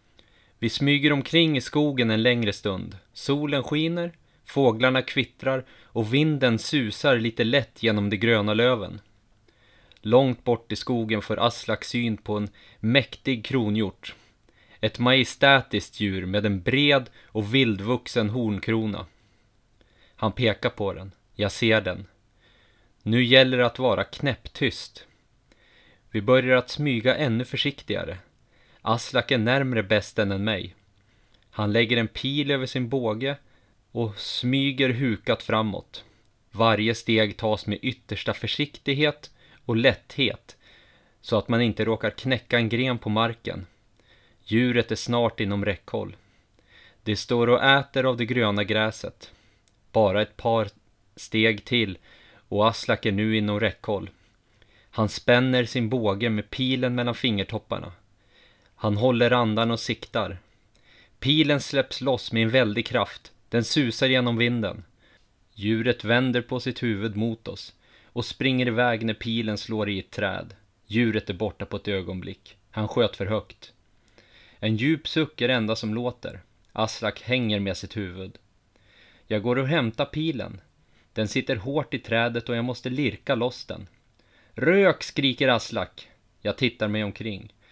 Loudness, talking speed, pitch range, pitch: -24 LUFS, 140 wpm, 105-125 Hz, 115 Hz